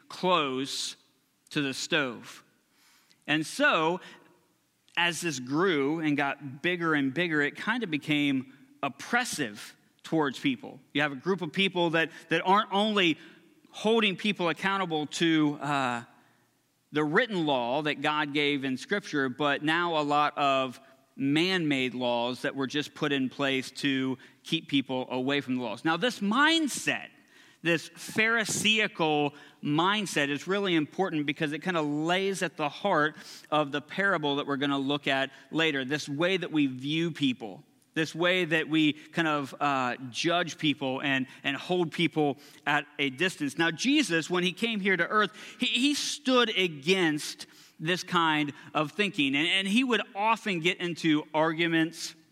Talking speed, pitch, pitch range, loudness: 160 wpm, 155 Hz, 145-185 Hz, -28 LUFS